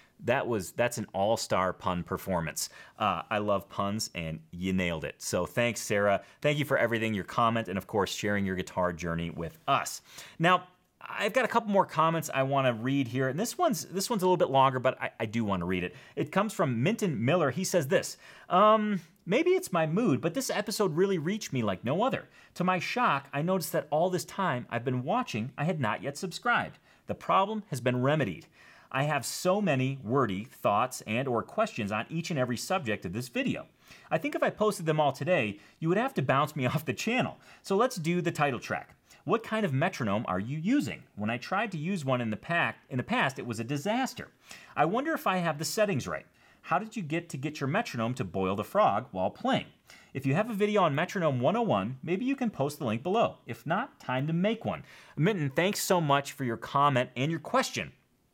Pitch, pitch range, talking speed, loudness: 150 Hz, 120-190 Hz, 230 wpm, -30 LUFS